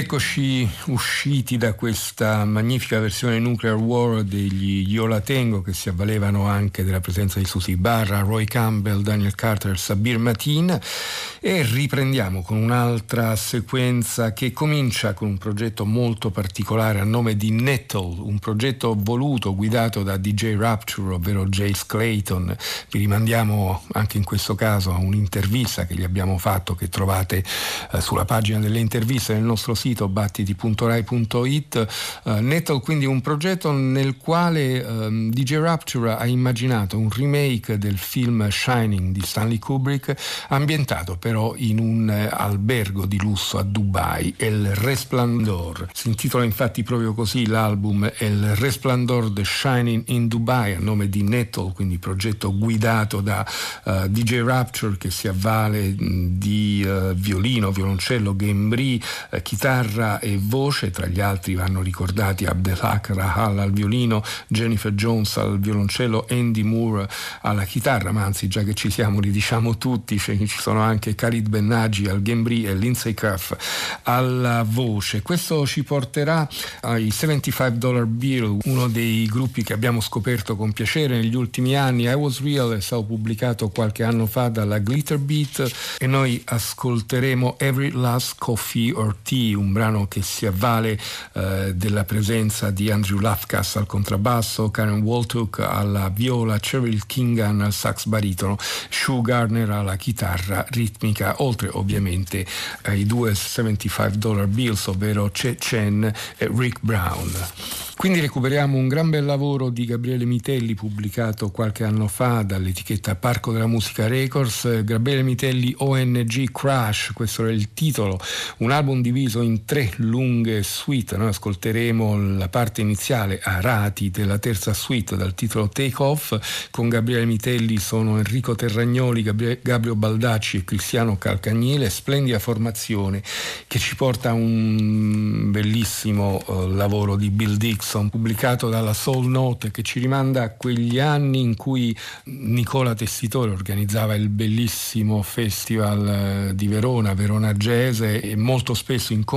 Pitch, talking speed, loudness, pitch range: 110 Hz, 145 wpm, -22 LUFS, 105-120 Hz